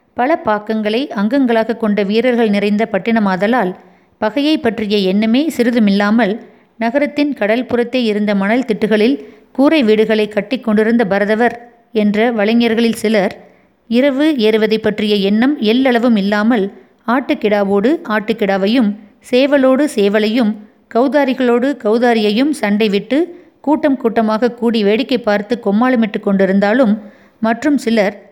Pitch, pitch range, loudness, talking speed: 225 Hz, 210-250 Hz, -14 LUFS, 100 wpm